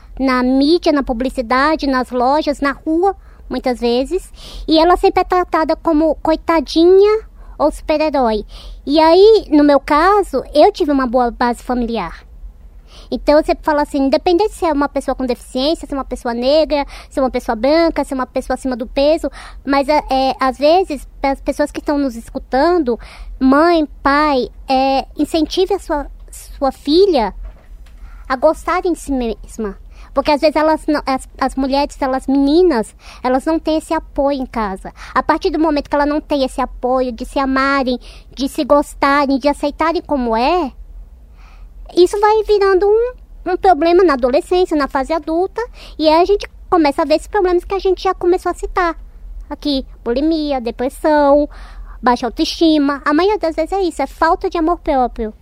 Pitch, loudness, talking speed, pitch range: 290 Hz, -15 LUFS, 175 wpm, 260-330 Hz